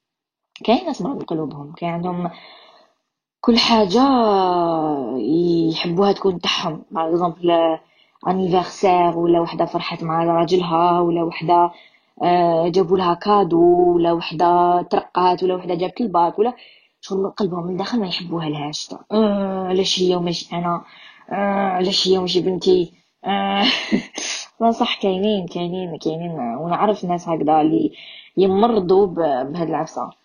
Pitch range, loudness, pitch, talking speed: 170-195 Hz, -19 LUFS, 175 Hz, 125 wpm